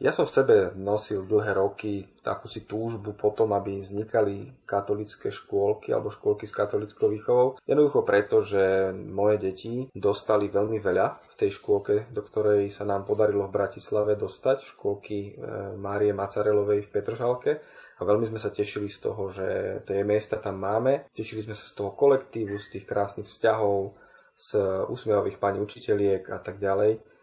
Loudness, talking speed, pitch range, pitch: -27 LUFS, 160 wpm, 100-130 Hz, 105 Hz